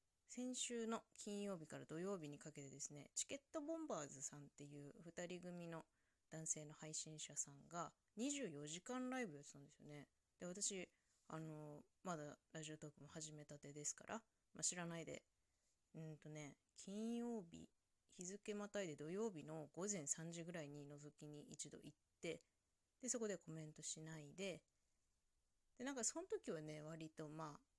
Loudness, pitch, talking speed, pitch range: -51 LUFS, 160 Hz, 315 characters per minute, 150-200 Hz